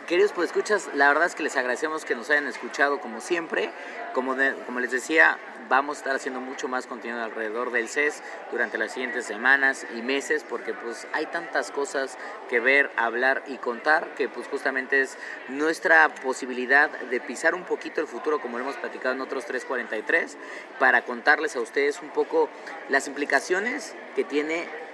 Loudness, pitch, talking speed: -25 LUFS, 150 Hz, 180 wpm